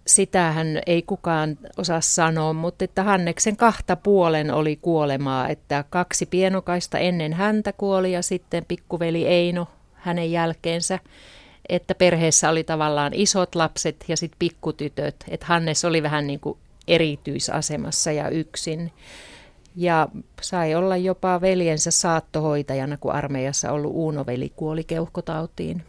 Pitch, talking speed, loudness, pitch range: 165 Hz, 125 wpm, -22 LUFS, 155-180 Hz